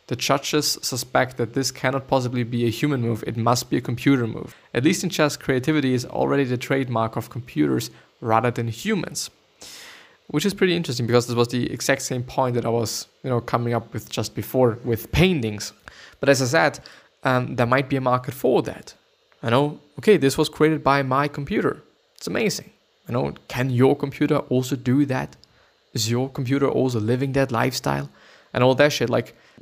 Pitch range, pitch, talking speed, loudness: 120-140 Hz, 130 Hz, 195 wpm, -22 LUFS